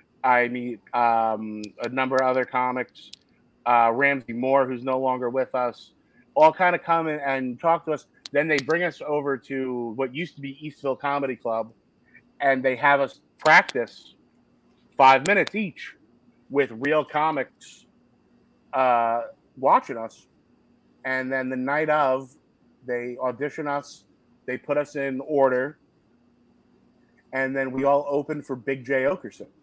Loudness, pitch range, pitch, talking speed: -24 LUFS, 125-145 Hz, 135 Hz, 150 wpm